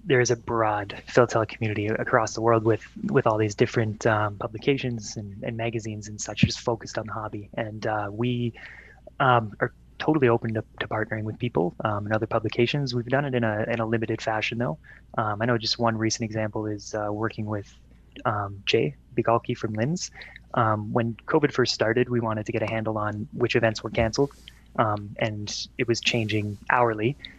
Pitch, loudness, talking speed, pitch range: 115 Hz, -26 LUFS, 195 wpm, 110-120 Hz